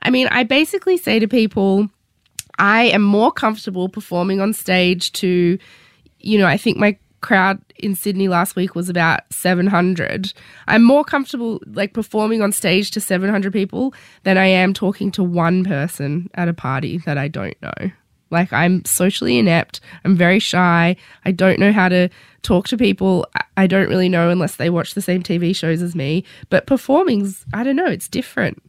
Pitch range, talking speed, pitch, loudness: 175-210 Hz, 185 wpm, 190 Hz, -17 LUFS